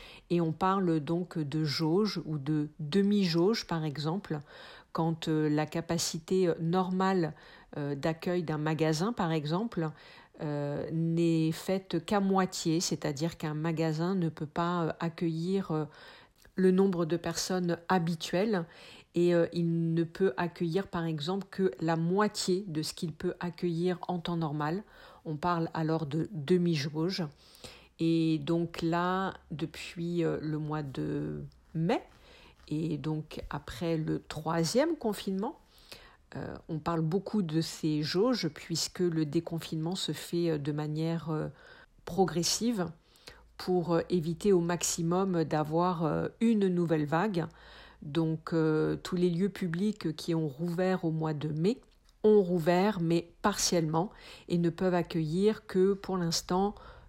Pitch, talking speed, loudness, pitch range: 170 Hz, 125 wpm, -31 LUFS, 160-185 Hz